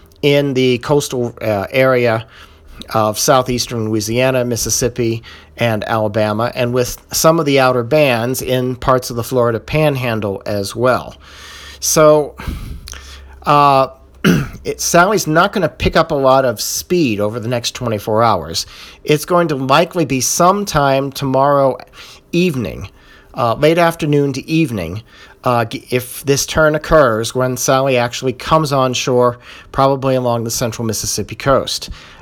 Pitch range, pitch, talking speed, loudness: 110-145 Hz, 125 Hz, 140 wpm, -15 LUFS